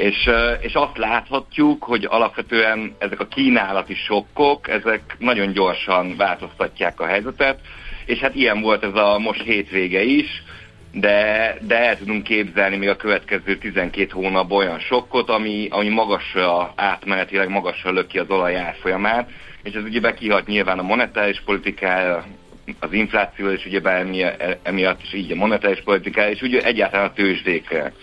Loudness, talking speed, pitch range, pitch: -19 LUFS, 150 wpm, 95-110 Hz, 100 Hz